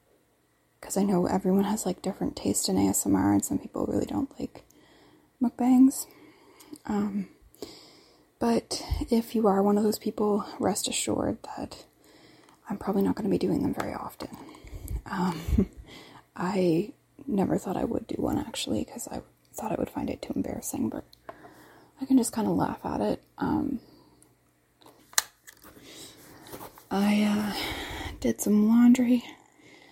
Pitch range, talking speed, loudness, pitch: 195-260 Hz, 145 wpm, -27 LUFS, 215 Hz